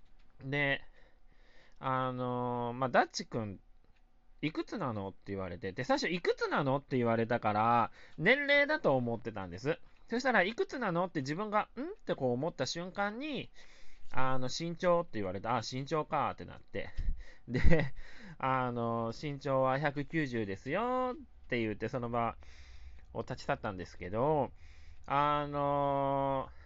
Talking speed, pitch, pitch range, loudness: 285 characters per minute, 130 Hz, 115-170 Hz, -34 LUFS